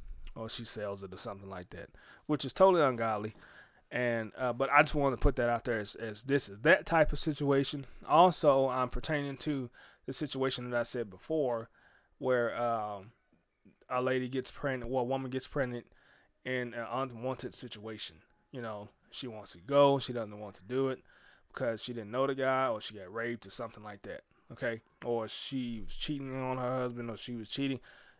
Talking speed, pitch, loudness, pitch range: 200 wpm, 125 Hz, -33 LUFS, 115-135 Hz